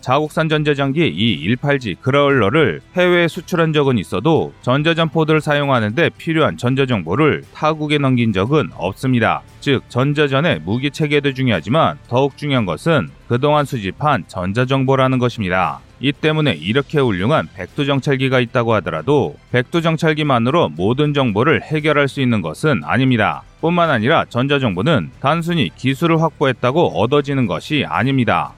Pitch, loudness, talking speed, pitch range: 135 Hz, -17 LUFS, 360 characters per minute, 120-150 Hz